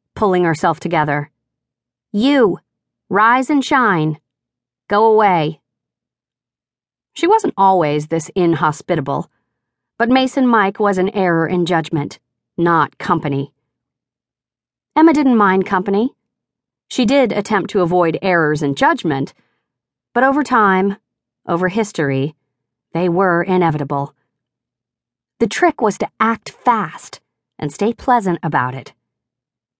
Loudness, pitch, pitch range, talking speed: -16 LUFS, 175 Hz, 140-215 Hz, 110 wpm